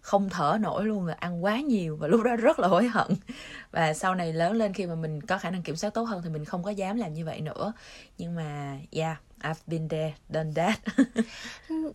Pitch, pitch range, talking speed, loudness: 180 Hz, 160-215 Hz, 235 wpm, -29 LUFS